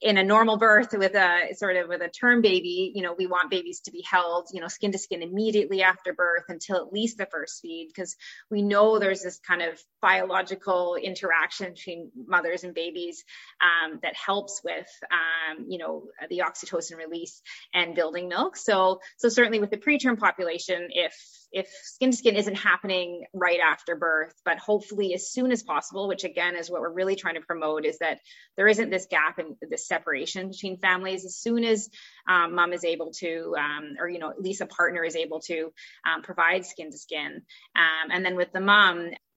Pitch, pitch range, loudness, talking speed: 180 Hz, 170-200 Hz, -25 LUFS, 205 wpm